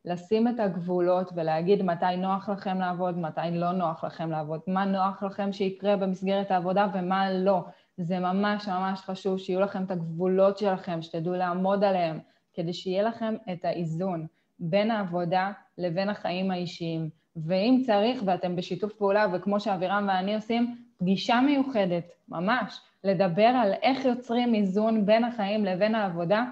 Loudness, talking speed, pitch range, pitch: -27 LUFS, 145 wpm, 180-210 Hz, 190 Hz